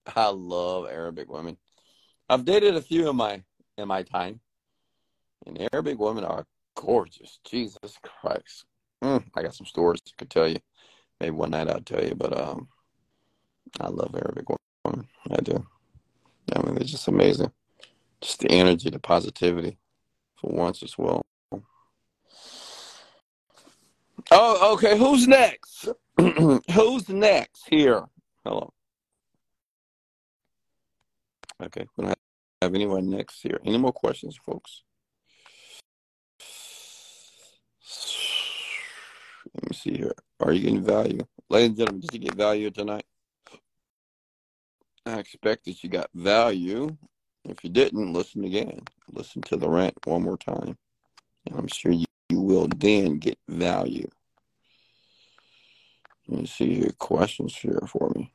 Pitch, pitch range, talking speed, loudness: 100 Hz, 85-145 Hz, 130 wpm, -25 LUFS